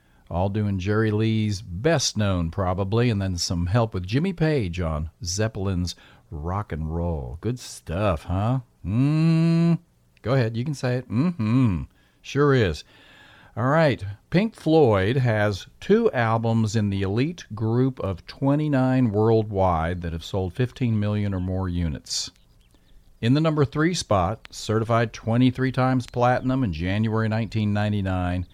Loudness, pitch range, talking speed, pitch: -24 LUFS, 95-130 Hz, 140 wpm, 110 Hz